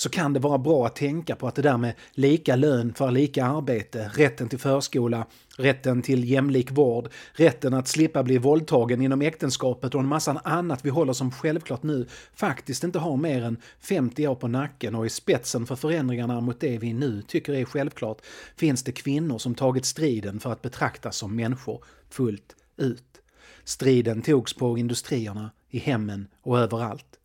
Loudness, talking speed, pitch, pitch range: -25 LUFS, 180 wpm, 130 Hz, 120-145 Hz